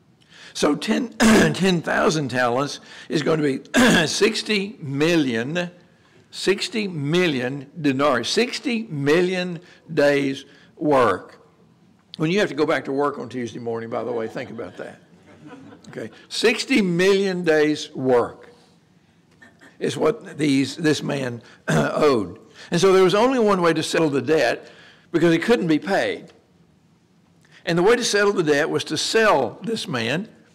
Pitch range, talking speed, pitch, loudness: 145-195 Hz, 145 wpm, 165 Hz, -21 LUFS